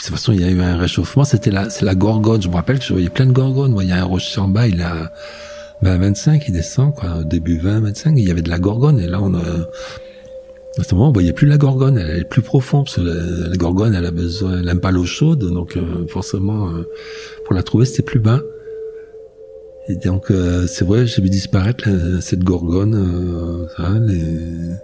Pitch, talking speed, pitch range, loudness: 100 Hz, 245 wpm, 90-135 Hz, -16 LUFS